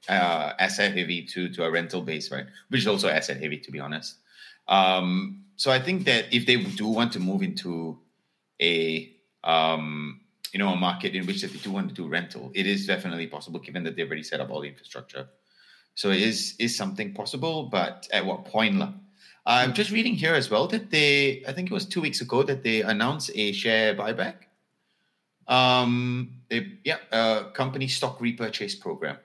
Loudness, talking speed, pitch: -25 LUFS, 195 wpm, 120 Hz